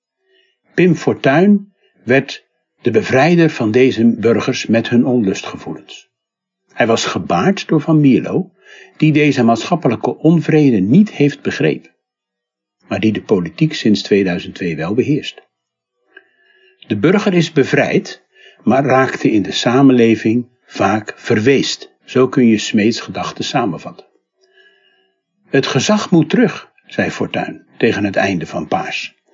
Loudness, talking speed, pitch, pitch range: -14 LUFS, 125 wpm, 155 Hz, 130-205 Hz